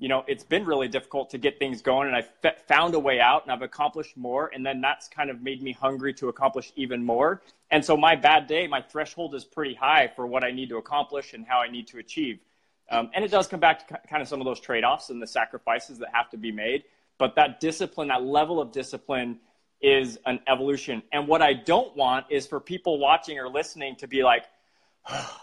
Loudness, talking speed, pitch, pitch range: -25 LUFS, 240 wpm, 135 Hz, 130-150 Hz